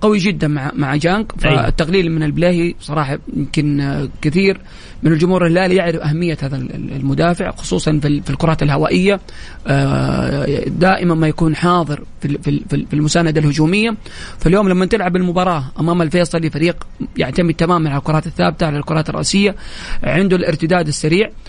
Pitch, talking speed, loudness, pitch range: 165 Hz, 135 wpm, -16 LUFS, 150-180 Hz